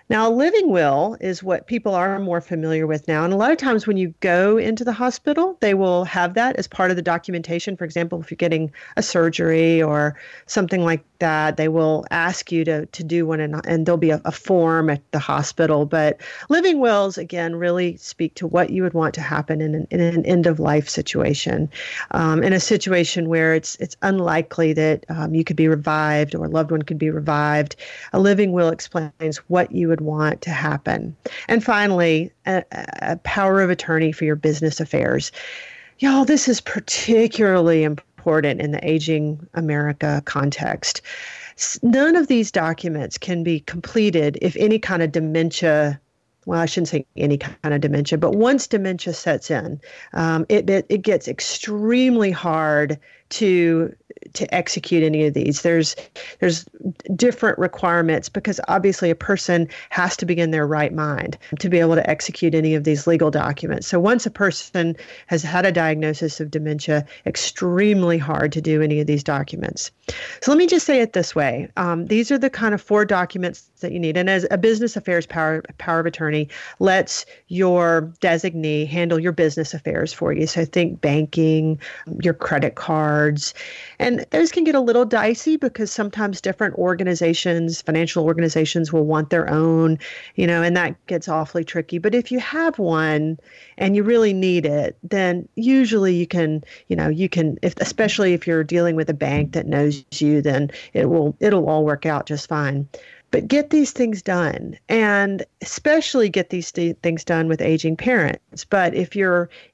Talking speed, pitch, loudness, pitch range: 185 wpm, 170 Hz, -20 LUFS, 155-195 Hz